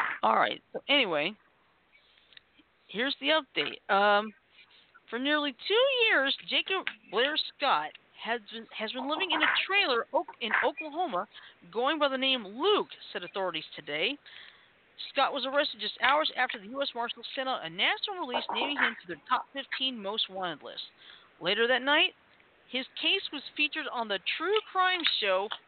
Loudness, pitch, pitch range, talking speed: -29 LUFS, 270 Hz, 225-310 Hz, 155 wpm